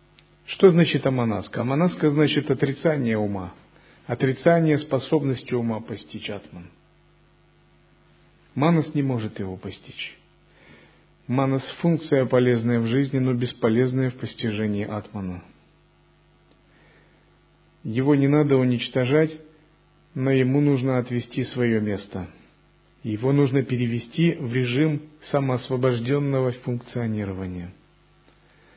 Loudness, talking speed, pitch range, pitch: -23 LUFS, 90 wpm, 115-145 Hz, 130 Hz